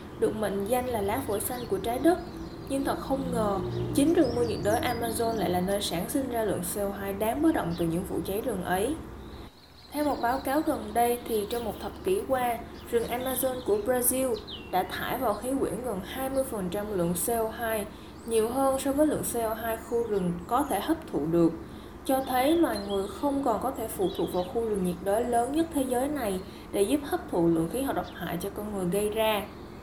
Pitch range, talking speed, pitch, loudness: 200-265 Hz, 220 wpm, 230 Hz, -29 LUFS